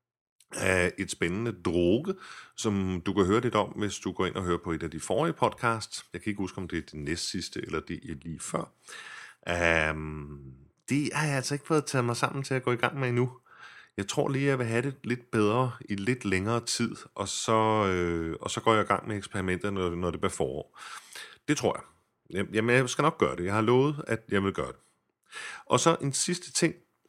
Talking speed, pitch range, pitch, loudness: 235 wpm, 90-130 Hz, 110 Hz, -29 LUFS